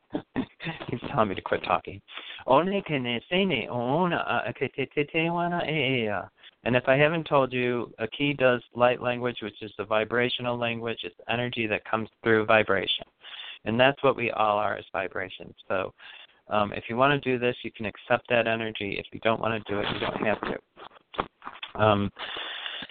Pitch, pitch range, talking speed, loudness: 120 Hz, 110-130 Hz, 160 wpm, -27 LUFS